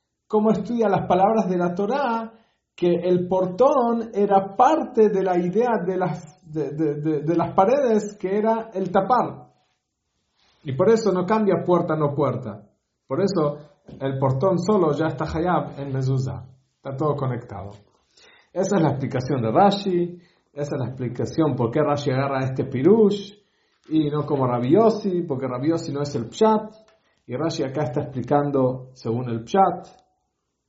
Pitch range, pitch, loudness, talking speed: 140-195 Hz, 170 Hz, -22 LUFS, 160 wpm